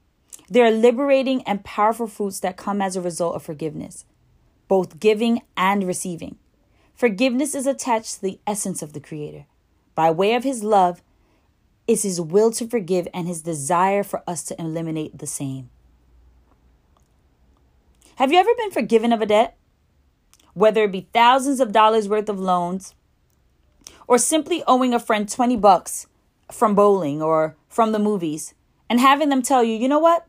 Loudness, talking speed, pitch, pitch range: -20 LUFS, 165 wpm, 200 Hz, 160-235 Hz